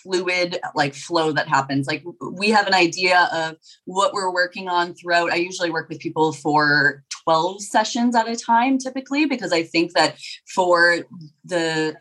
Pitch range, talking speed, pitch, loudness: 160-185 Hz, 170 wpm, 175 Hz, -20 LUFS